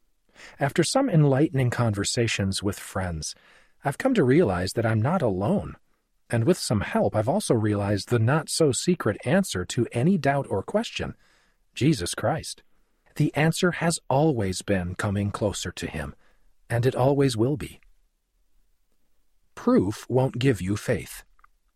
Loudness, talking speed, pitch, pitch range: -25 LUFS, 145 wpm, 125 Hz, 100-155 Hz